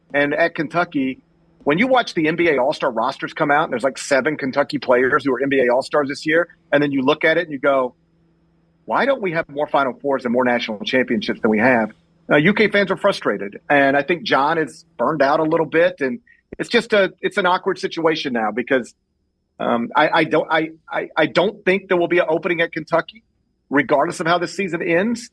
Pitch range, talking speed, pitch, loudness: 145-180 Hz, 225 wpm, 165 Hz, -19 LUFS